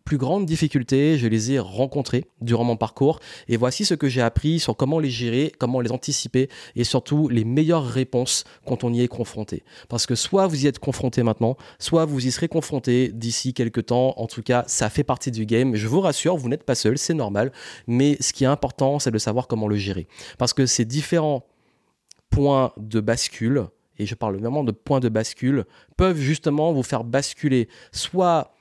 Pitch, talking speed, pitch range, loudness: 130 Hz, 205 wpm, 115-145 Hz, -22 LUFS